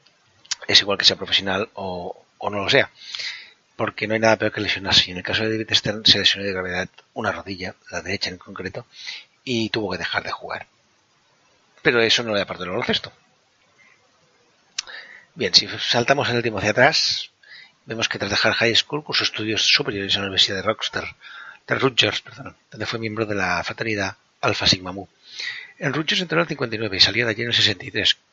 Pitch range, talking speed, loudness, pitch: 100-115 Hz, 200 wpm, -20 LUFS, 110 Hz